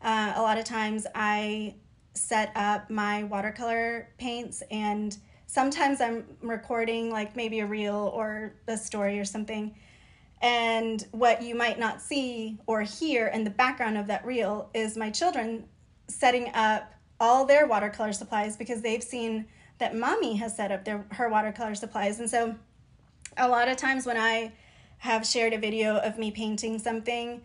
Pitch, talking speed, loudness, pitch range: 225 Hz, 165 wpm, -28 LUFS, 215-235 Hz